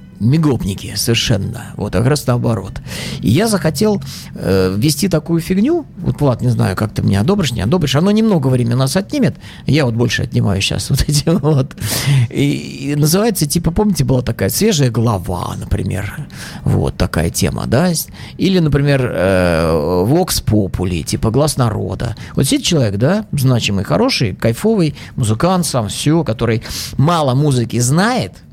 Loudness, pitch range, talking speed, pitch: -15 LUFS, 110-160 Hz, 155 wpm, 130 Hz